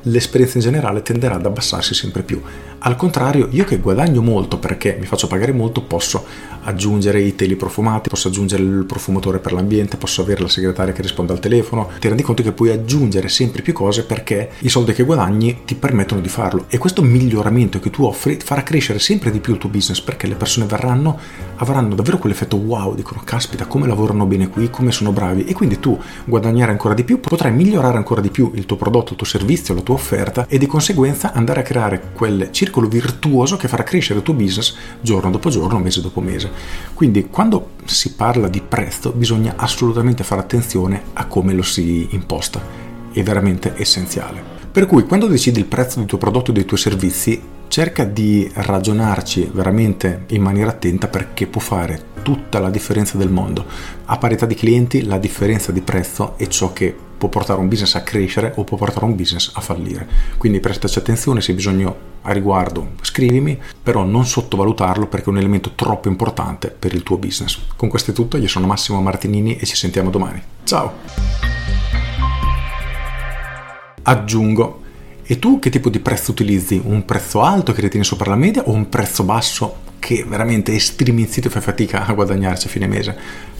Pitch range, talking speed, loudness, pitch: 95-120 Hz, 190 wpm, -17 LUFS, 105 Hz